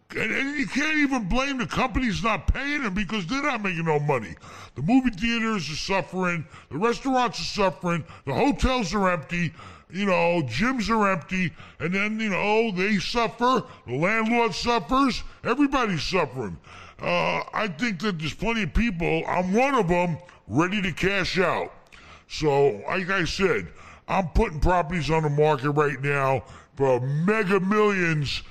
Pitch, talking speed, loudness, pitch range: 190 Hz, 160 wpm, -24 LUFS, 155-225 Hz